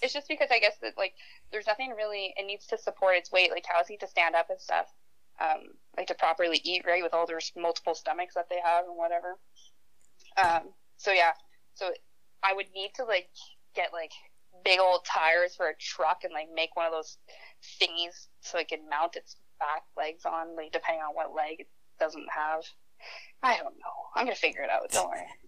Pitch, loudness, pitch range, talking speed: 175 Hz, -30 LUFS, 165-195 Hz, 210 wpm